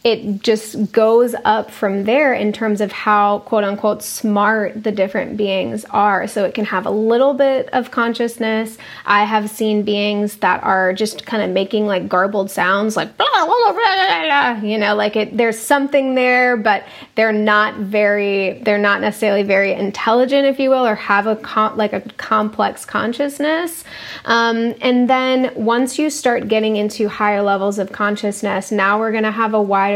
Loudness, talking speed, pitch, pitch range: -16 LUFS, 180 wpm, 215 Hz, 205-240 Hz